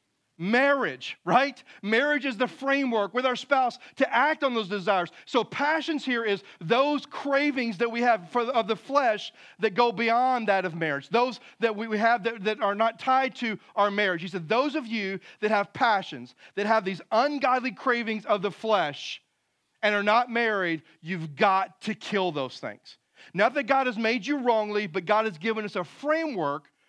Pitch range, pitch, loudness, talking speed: 205-255 Hz, 225 Hz, -26 LUFS, 190 wpm